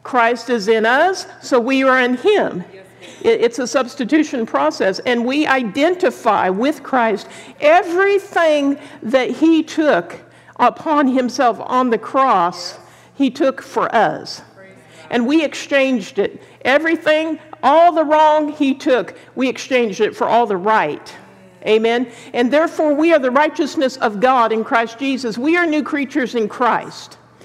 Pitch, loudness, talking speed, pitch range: 270 Hz, -16 LUFS, 145 wpm, 240-310 Hz